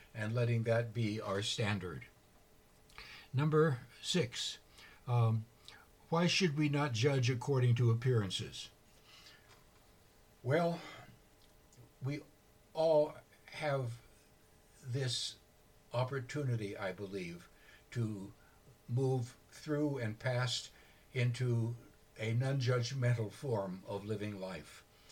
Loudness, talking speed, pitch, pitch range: -36 LUFS, 90 wpm, 120 Hz, 105-135 Hz